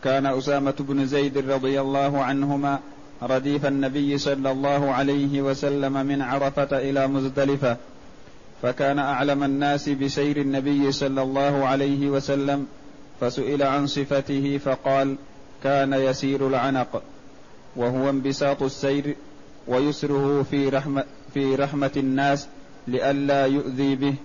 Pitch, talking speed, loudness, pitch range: 140 Hz, 110 wpm, -23 LUFS, 135-140 Hz